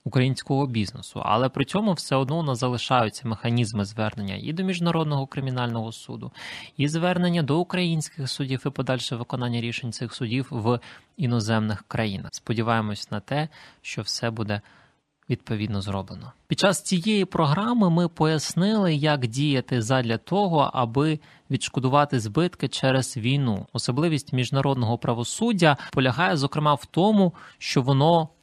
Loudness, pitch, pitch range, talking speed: -24 LUFS, 135 Hz, 120-155 Hz, 135 wpm